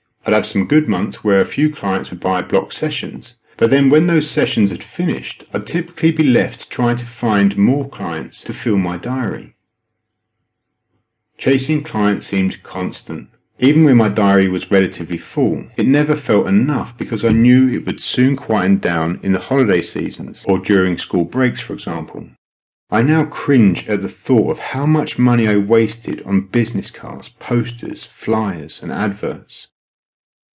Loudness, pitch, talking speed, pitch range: -16 LUFS, 115 Hz, 165 wpm, 100-135 Hz